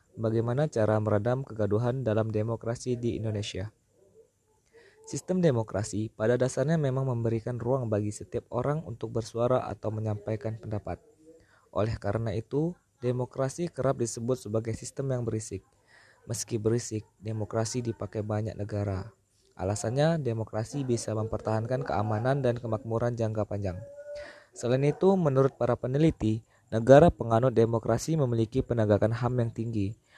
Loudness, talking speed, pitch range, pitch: -29 LUFS, 120 wpm, 110-130 Hz, 115 Hz